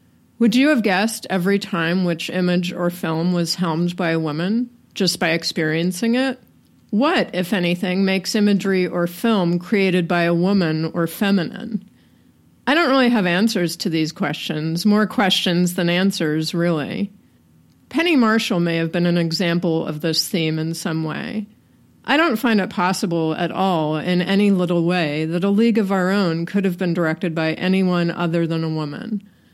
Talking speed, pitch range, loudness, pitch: 175 wpm, 170-205 Hz, -19 LUFS, 180 Hz